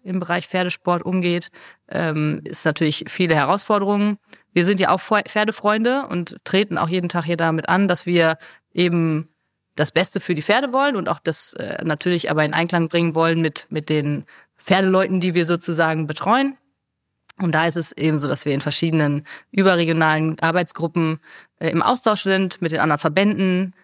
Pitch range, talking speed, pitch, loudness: 160-190 Hz, 165 wpm, 175 Hz, -20 LUFS